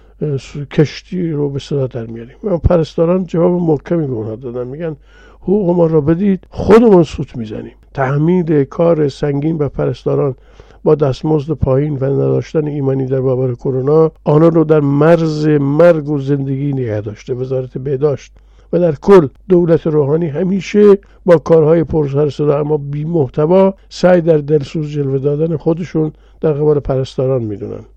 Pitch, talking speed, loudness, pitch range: 150 Hz, 140 wpm, -14 LUFS, 135-165 Hz